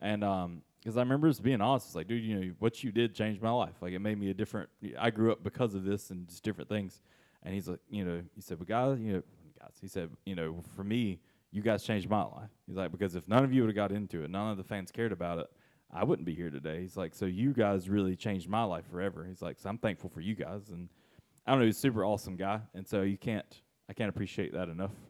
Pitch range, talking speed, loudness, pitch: 90-110 Hz, 280 wpm, -34 LUFS, 100 Hz